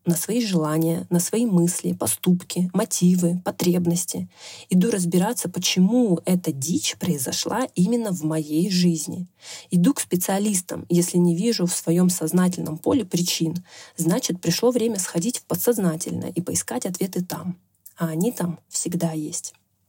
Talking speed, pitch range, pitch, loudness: 135 wpm, 165-185 Hz, 175 Hz, -22 LUFS